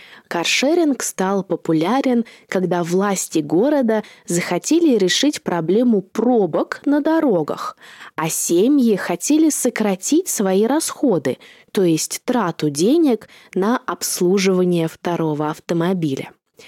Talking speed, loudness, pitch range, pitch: 95 wpm, -18 LUFS, 175-255 Hz, 200 Hz